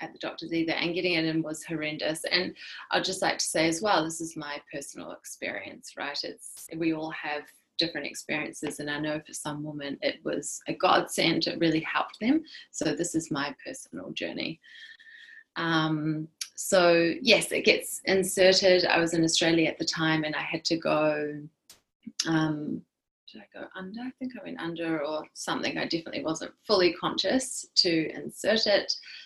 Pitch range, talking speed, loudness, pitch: 155-195 Hz, 180 wpm, -27 LUFS, 165 Hz